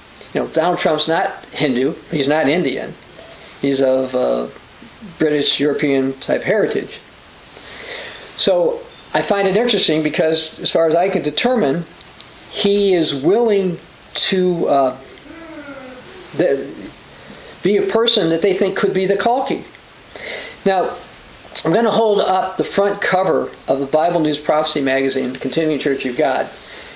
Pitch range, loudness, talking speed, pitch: 145-215 Hz, -17 LUFS, 140 wpm, 175 Hz